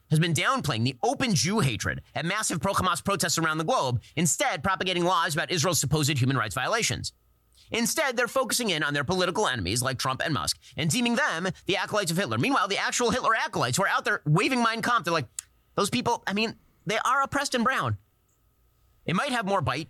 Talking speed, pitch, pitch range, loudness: 215 wpm, 175 Hz, 140-225 Hz, -26 LUFS